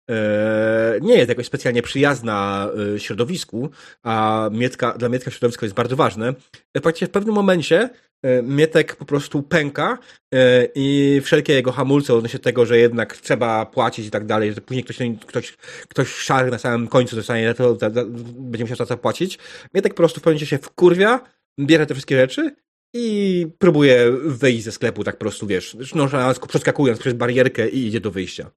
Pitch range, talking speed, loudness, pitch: 115-150 Hz, 170 wpm, -19 LUFS, 125 Hz